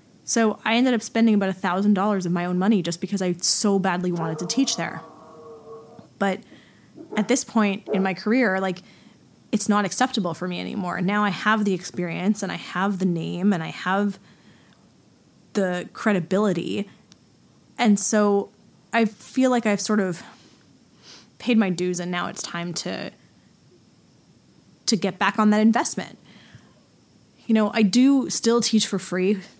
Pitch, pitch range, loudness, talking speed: 200 Hz, 180-220 Hz, -22 LUFS, 160 wpm